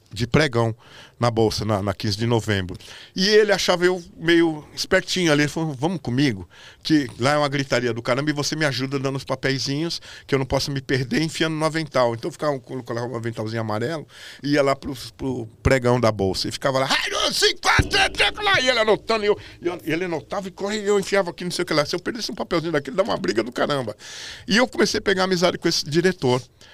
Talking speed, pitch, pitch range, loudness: 240 wpm, 145 Hz, 120-175 Hz, -22 LUFS